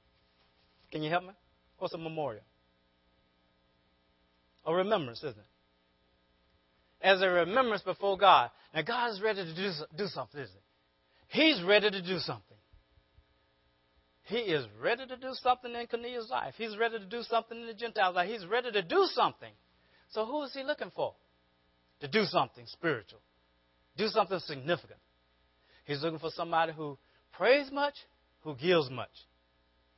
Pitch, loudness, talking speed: 155 Hz, -31 LUFS, 155 wpm